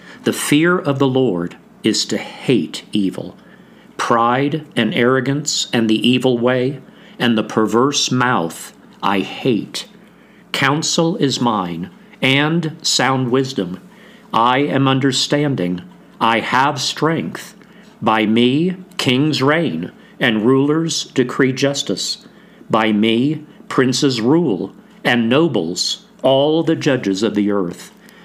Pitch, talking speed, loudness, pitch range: 135 Hz, 115 wpm, -17 LUFS, 120-150 Hz